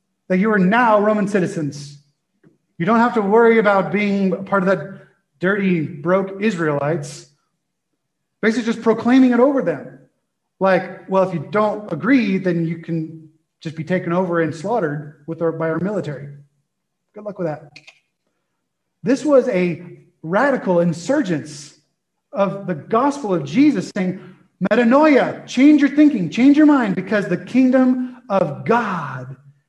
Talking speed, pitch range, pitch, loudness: 145 wpm, 165-225 Hz, 185 Hz, -18 LUFS